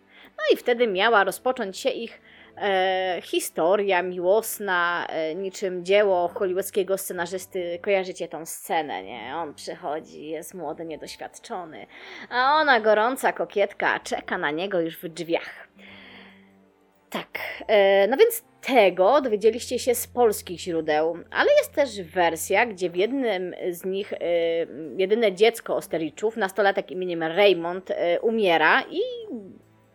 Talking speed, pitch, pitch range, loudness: 125 wpm, 195 Hz, 175-225 Hz, -24 LUFS